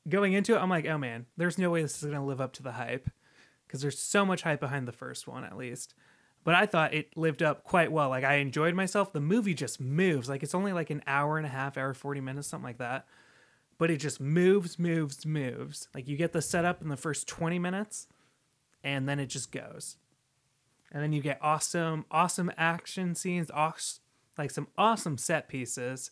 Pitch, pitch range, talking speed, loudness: 150 Hz, 140-170 Hz, 220 wpm, -31 LUFS